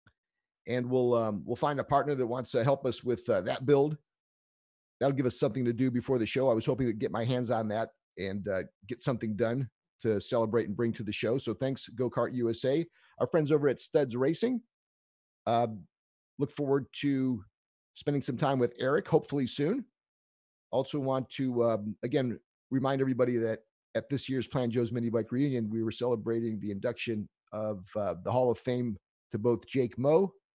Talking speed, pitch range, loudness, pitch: 195 wpm, 115-135 Hz, -31 LUFS, 120 Hz